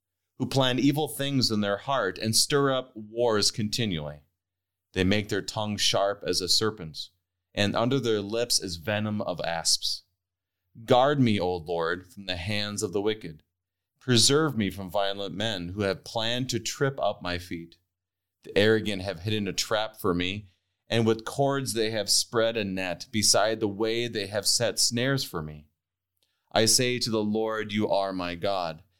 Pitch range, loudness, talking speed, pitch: 90-115 Hz, -26 LUFS, 175 wpm, 105 Hz